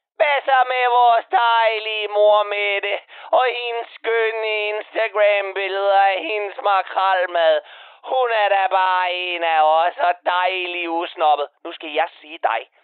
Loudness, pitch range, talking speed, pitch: -19 LUFS, 180-225 Hz, 130 wpm, 200 Hz